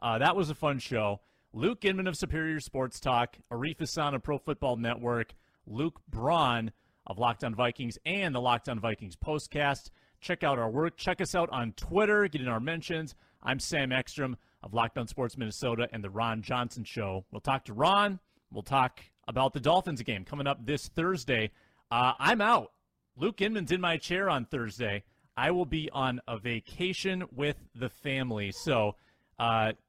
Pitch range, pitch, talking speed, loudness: 115-155 Hz, 130 Hz, 175 wpm, -31 LUFS